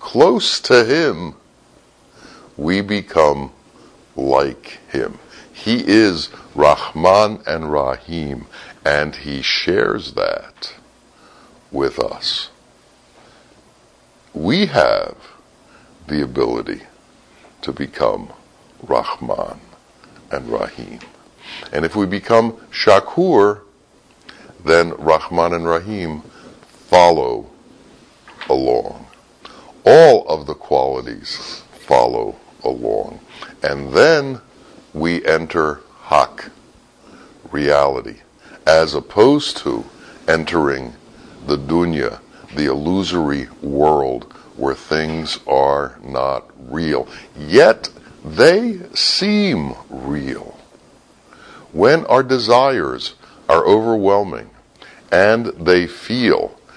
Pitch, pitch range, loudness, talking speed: 85 Hz, 75-105 Hz, -16 LUFS, 80 wpm